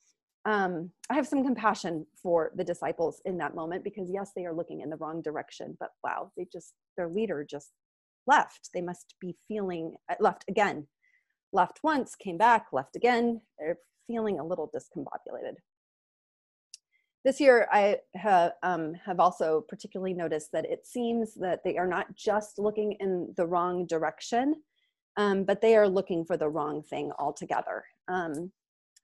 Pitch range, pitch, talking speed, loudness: 170-235 Hz, 195 Hz, 160 wpm, -29 LUFS